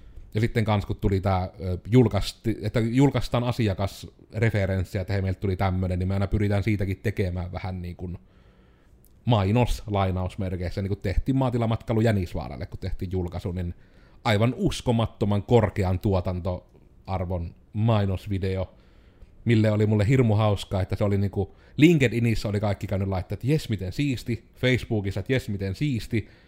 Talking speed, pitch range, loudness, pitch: 140 wpm, 95-115 Hz, -26 LUFS, 100 Hz